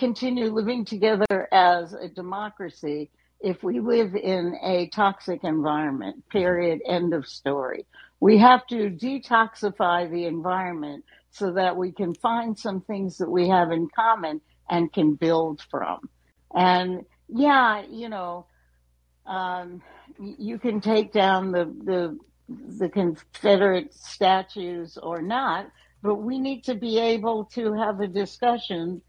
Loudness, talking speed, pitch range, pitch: -24 LUFS, 135 wpm, 175-225 Hz, 190 Hz